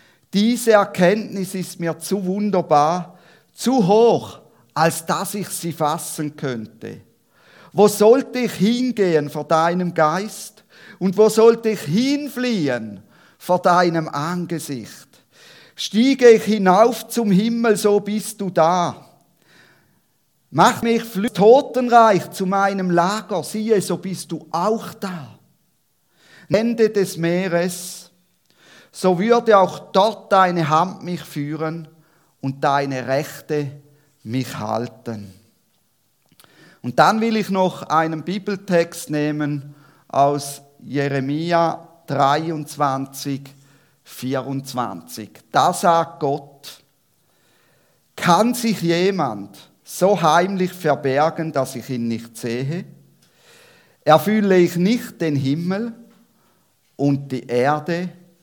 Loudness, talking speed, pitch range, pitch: -19 LUFS, 105 wpm, 145-205 Hz, 175 Hz